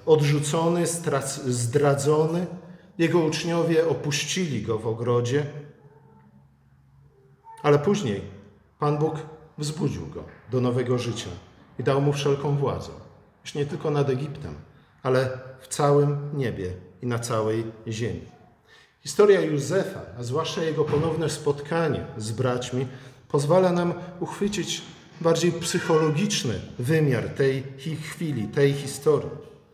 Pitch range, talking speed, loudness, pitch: 125-160 Hz, 110 wpm, -25 LUFS, 145 Hz